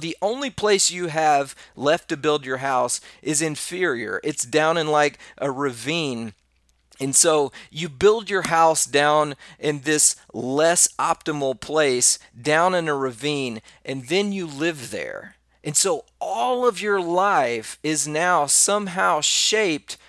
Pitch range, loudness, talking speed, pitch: 135-175 Hz, -21 LUFS, 145 wpm, 155 Hz